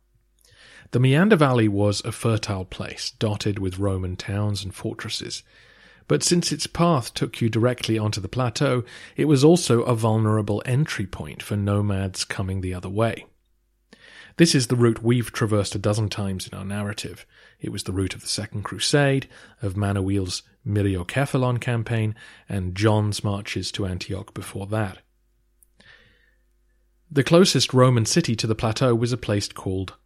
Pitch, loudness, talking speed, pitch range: 110 Hz, -23 LUFS, 155 wpm, 100-125 Hz